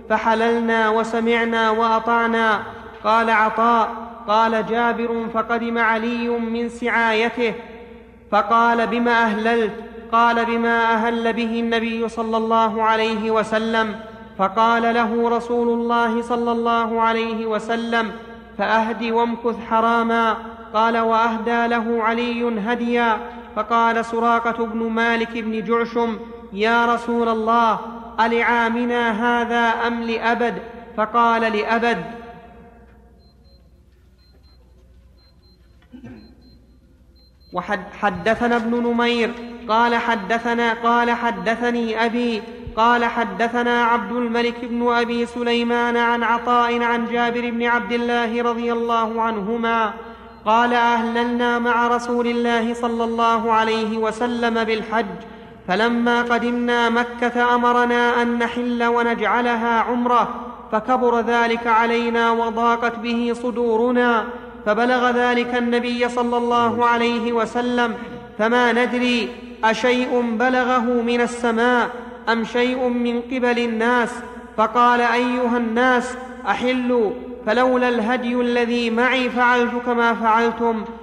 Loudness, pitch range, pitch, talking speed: -19 LUFS, 225-240 Hz, 235 Hz, 100 wpm